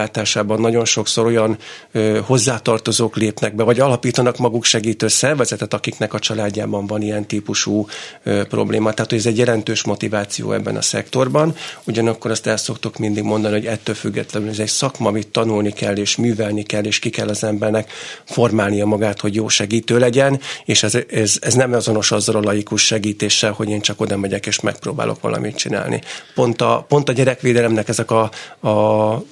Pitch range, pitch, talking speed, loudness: 105-120 Hz, 110 Hz, 175 wpm, -17 LUFS